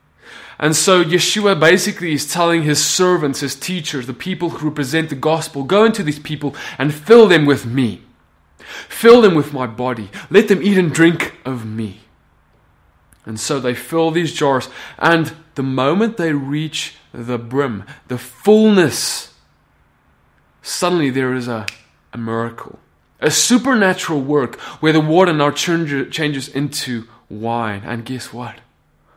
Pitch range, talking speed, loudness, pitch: 125-170 Hz, 145 wpm, -16 LUFS, 145 Hz